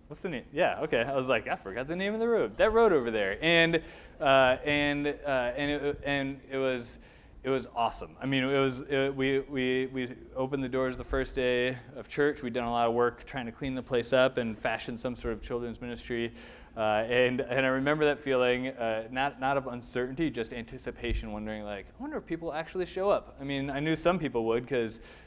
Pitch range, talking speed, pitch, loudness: 120-140 Hz, 230 wpm, 130 Hz, -30 LUFS